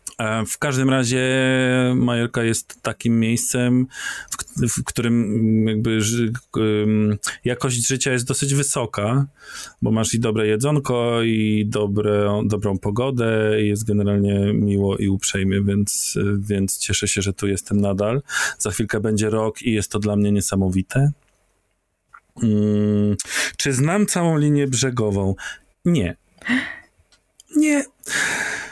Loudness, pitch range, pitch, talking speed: -20 LUFS, 105-125 Hz, 110 Hz, 120 wpm